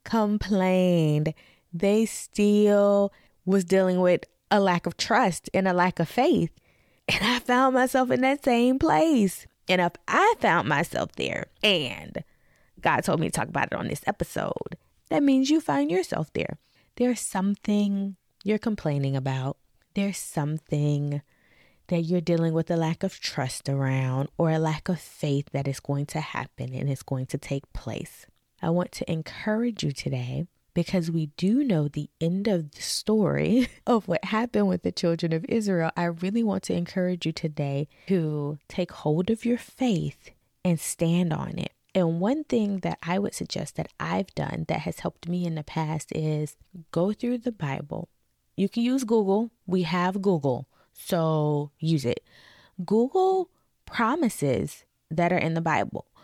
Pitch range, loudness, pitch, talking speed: 155-210 Hz, -26 LUFS, 180 Hz, 170 wpm